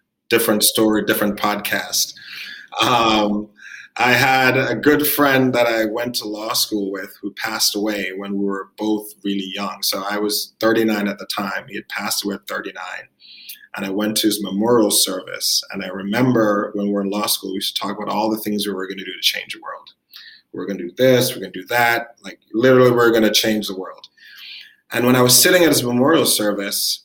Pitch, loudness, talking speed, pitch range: 105 Hz, -18 LUFS, 225 wpm, 100-120 Hz